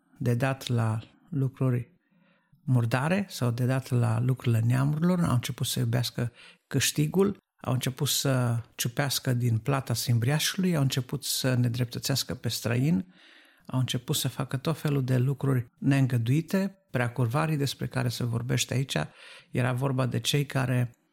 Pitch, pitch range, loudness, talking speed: 130 Hz, 125-145 Hz, -28 LUFS, 140 wpm